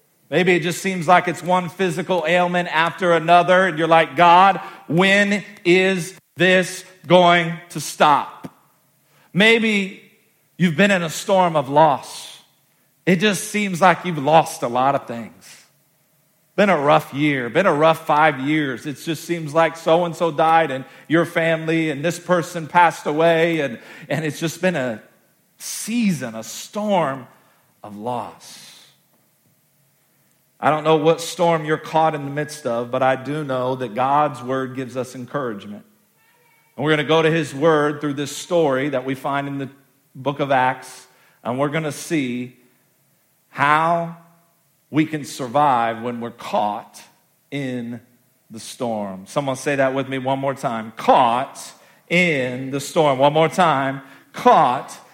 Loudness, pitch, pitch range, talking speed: -19 LUFS, 155 Hz, 135-175 Hz, 160 wpm